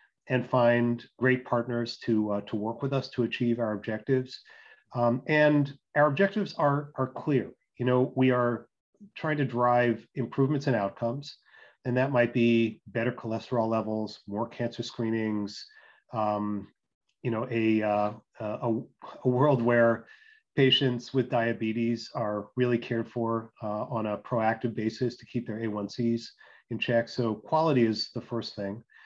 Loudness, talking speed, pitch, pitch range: -28 LUFS, 155 wpm, 120 Hz, 110-130 Hz